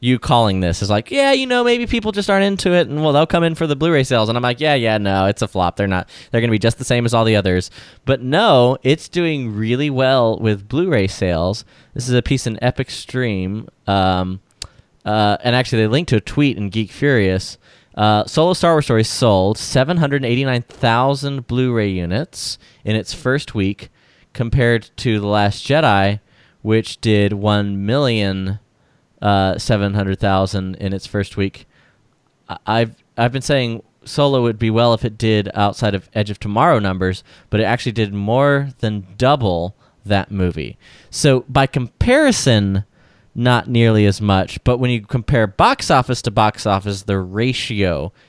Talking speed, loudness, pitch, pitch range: 185 wpm, -17 LUFS, 115 Hz, 100-130 Hz